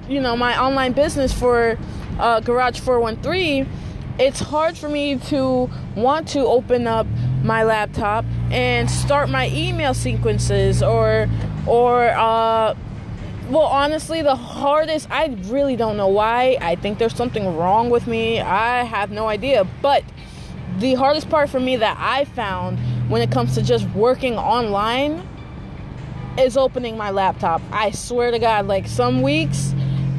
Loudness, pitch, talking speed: -19 LUFS, 230 Hz, 150 wpm